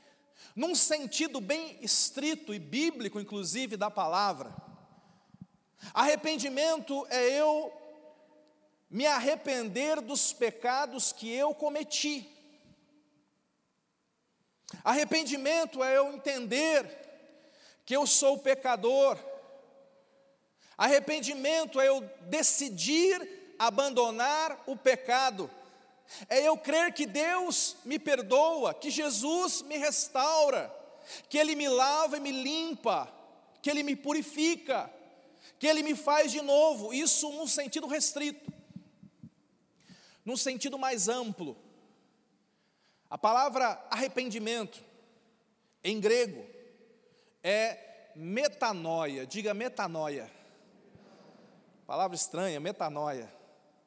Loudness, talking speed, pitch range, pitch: -29 LUFS, 90 wpm, 230-300 Hz, 275 Hz